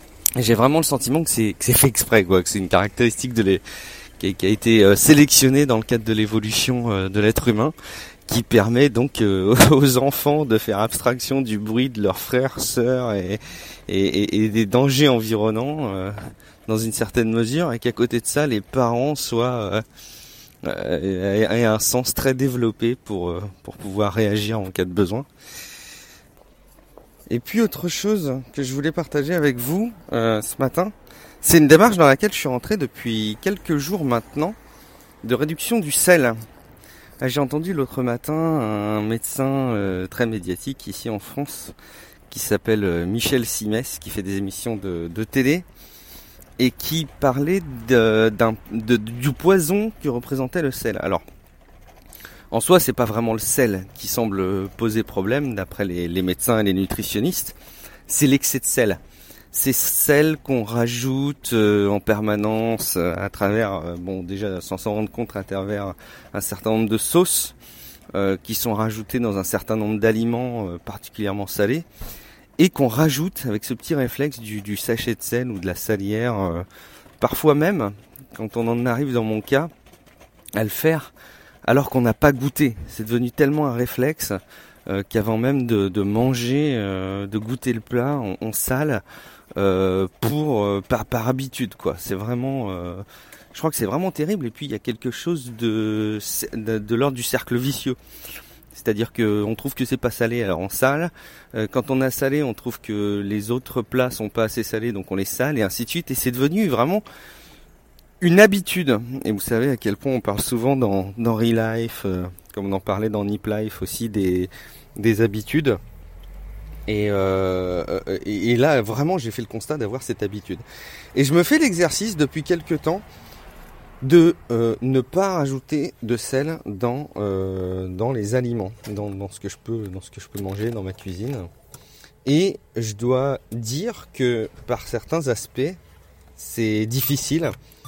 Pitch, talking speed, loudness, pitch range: 115 Hz, 175 wpm, -21 LUFS, 105-135 Hz